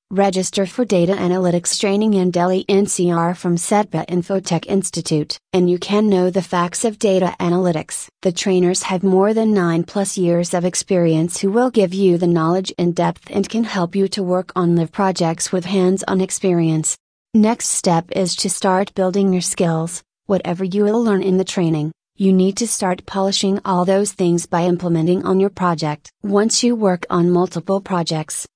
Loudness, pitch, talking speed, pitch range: -18 LUFS, 185 Hz, 180 wpm, 175-195 Hz